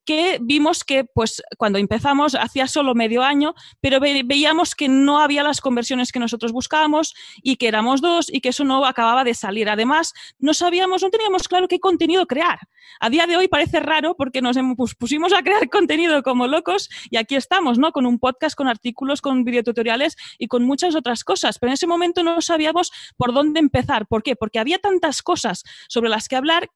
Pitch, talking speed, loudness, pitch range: 285 Hz, 200 wpm, -19 LUFS, 245-335 Hz